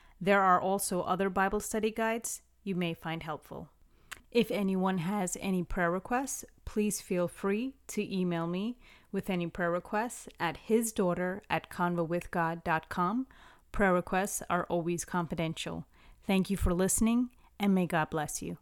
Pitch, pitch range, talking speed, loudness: 185 Hz, 175-210 Hz, 140 wpm, -32 LUFS